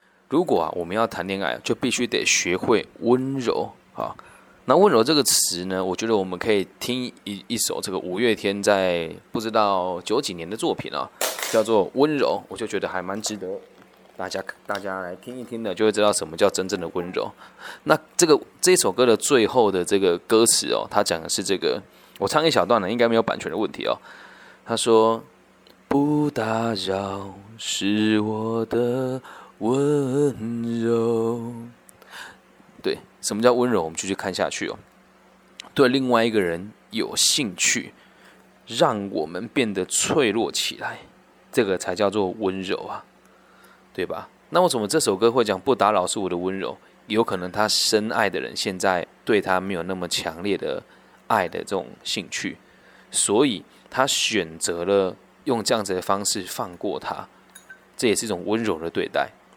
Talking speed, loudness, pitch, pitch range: 245 characters per minute, -23 LUFS, 110 Hz, 95-120 Hz